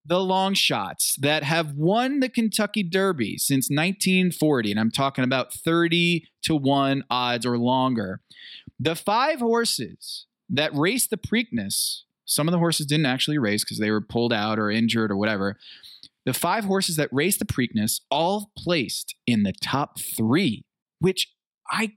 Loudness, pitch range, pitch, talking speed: -23 LUFS, 125-190 Hz, 155 Hz, 160 wpm